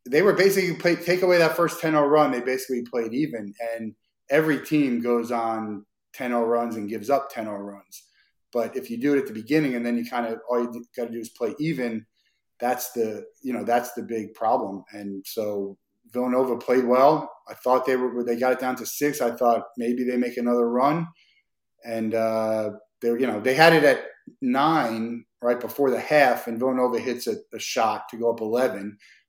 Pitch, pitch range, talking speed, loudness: 120 Hz, 115-135 Hz, 205 wpm, -24 LUFS